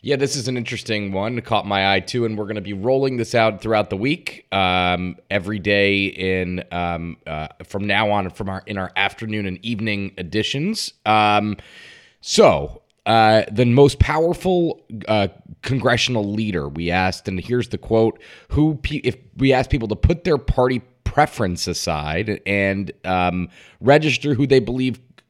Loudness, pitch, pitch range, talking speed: -20 LUFS, 105 Hz, 95-125 Hz, 170 wpm